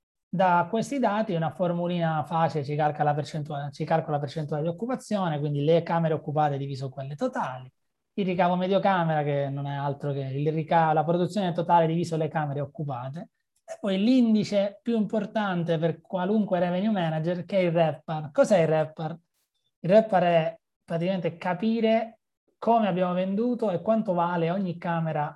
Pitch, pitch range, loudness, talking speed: 170 Hz, 155-195 Hz, -26 LUFS, 165 wpm